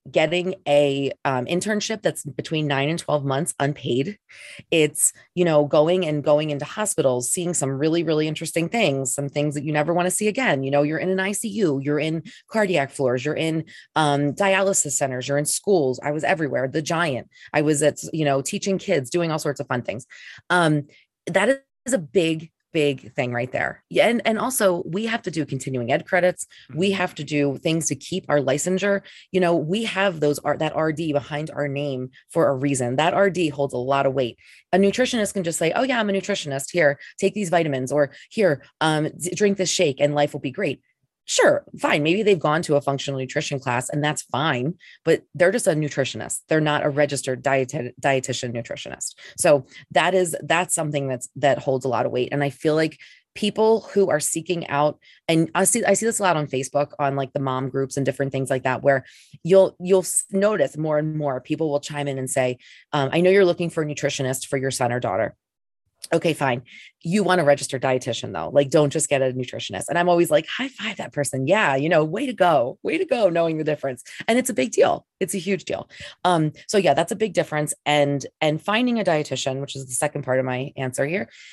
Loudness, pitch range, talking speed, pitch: -22 LUFS, 140-180 Hz, 220 wpm, 150 Hz